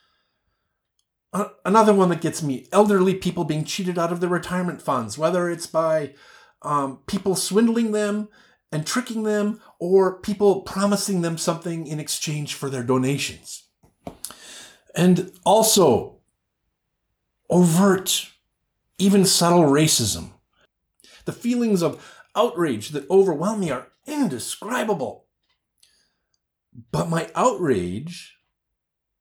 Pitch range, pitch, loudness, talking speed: 155-205 Hz, 180 Hz, -21 LUFS, 110 wpm